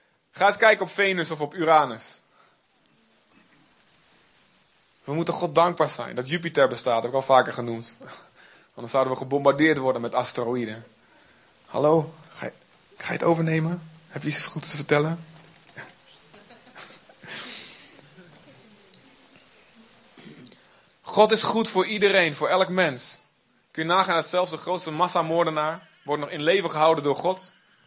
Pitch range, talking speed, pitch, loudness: 140-175 Hz, 140 wpm, 160 Hz, -23 LUFS